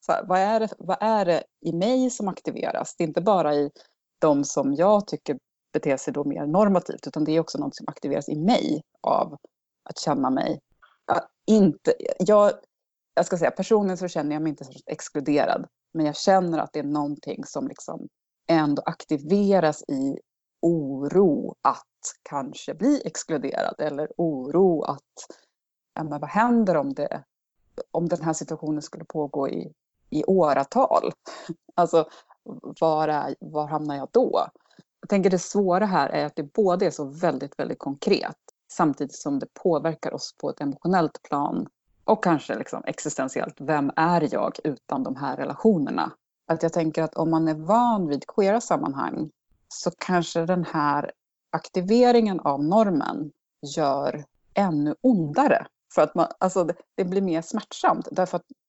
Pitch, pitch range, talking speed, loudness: 165 Hz, 150-200 Hz, 165 wpm, -24 LUFS